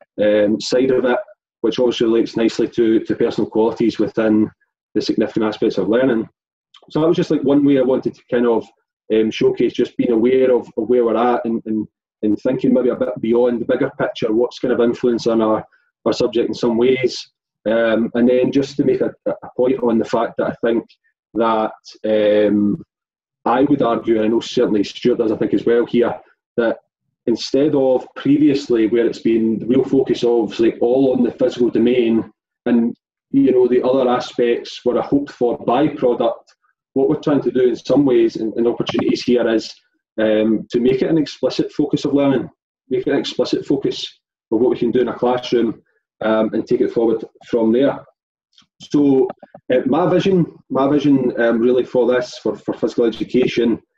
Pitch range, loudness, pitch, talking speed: 115-140 Hz, -17 LUFS, 125 Hz, 195 wpm